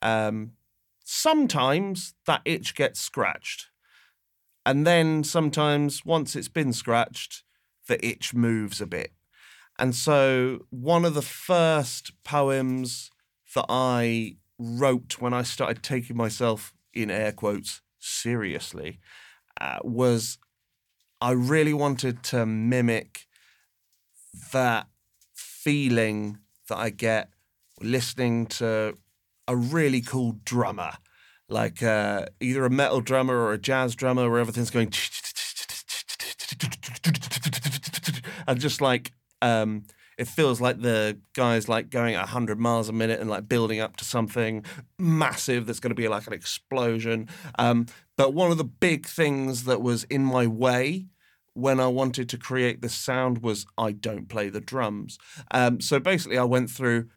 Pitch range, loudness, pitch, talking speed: 115-135 Hz, -26 LUFS, 125 Hz, 135 wpm